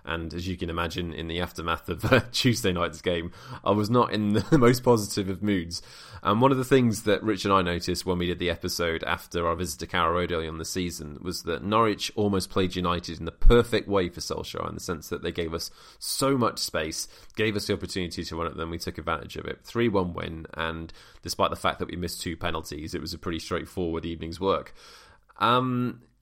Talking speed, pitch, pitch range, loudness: 235 wpm, 90 Hz, 85-105 Hz, -27 LUFS